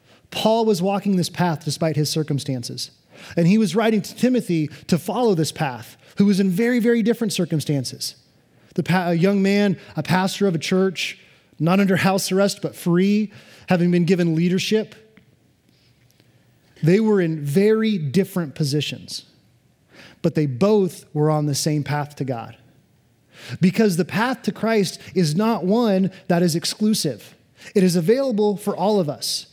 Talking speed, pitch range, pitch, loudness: 160 wpm, 155-205 Hz, 185 Hz, -20 LUFS